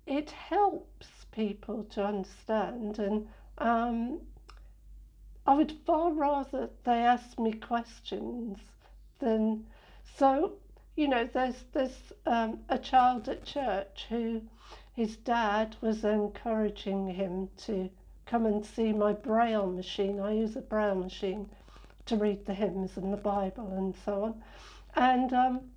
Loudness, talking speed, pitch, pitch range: -31 LUFS, 130 wpm, 225 Hz, 205-255 Hz